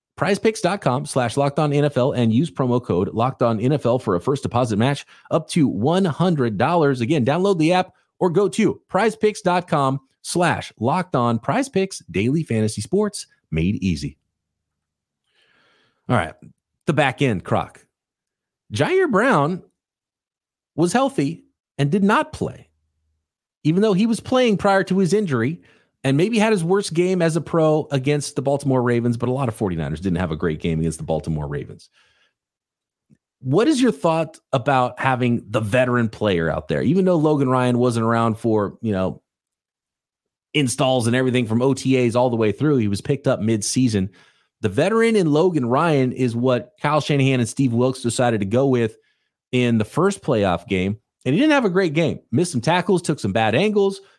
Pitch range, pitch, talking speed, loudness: 115-170 Hz, 130 Hz, 175 wpm, -20 LUFS